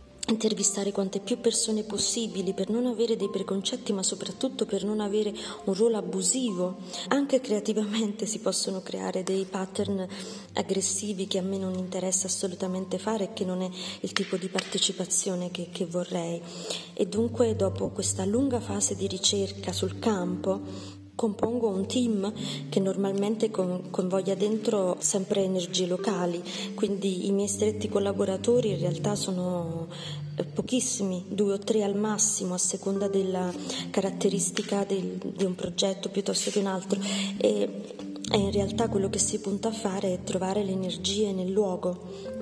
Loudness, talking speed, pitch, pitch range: -28 LUFS, 150 wpm, 195 Hz, 185-210 Hz